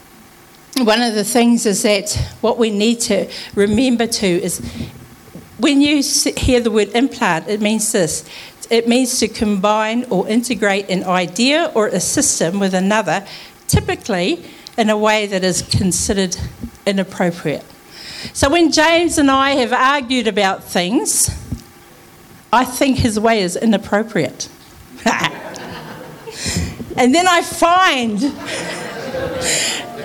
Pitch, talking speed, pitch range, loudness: 225 Hz, 125 wpm, 195-260 Hz, -16 LUFS